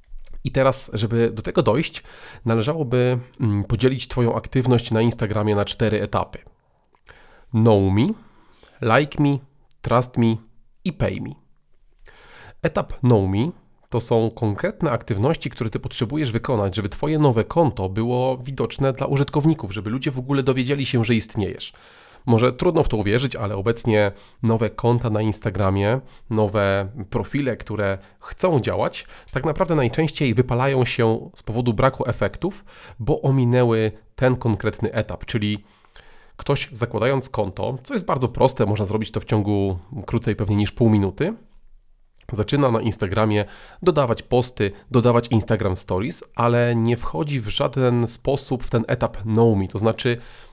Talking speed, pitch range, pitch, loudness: 145 wpm, 110-130 Hz, 115 Hz, -21 LUFS